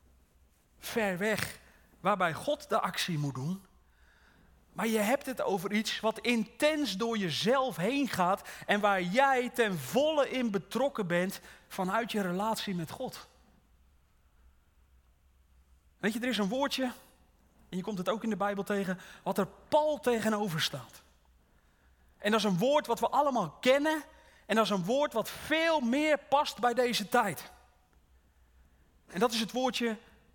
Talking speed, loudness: 155 wpm, -31 LUFS